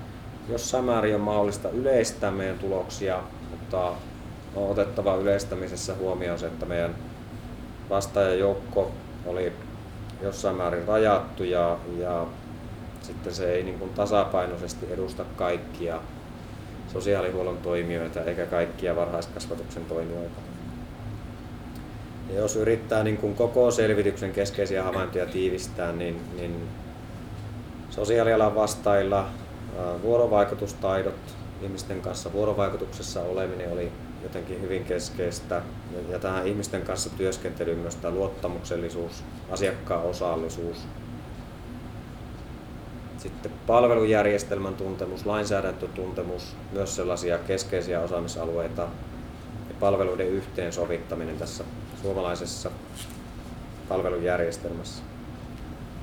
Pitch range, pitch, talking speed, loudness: 85-105 Hz, 95 Hz, 90 wpm, -28 LUFS